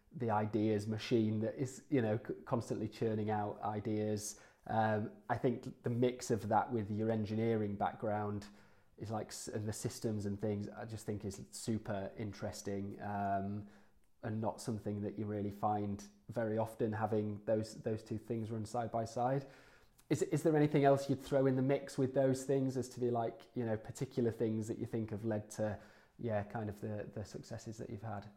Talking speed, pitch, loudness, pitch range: 190 wpm, 110 Hz, -38 LUFS, 105-120 Hz